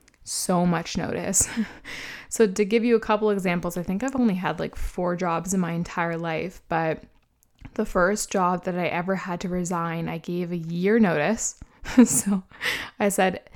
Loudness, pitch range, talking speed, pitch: -24 LUFS, 175-210 Hz, 175 wpm, 180 Hz